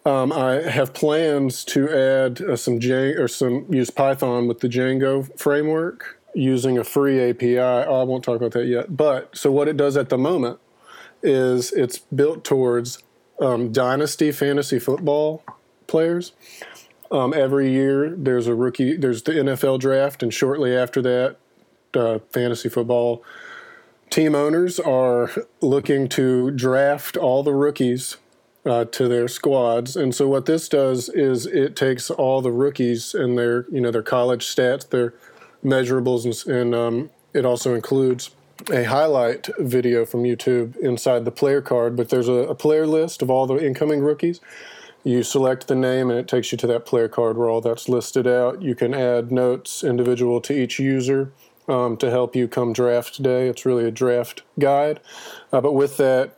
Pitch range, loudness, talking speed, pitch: 120-140 Hz, -20 LUFS, 170 wpm, 130 Hz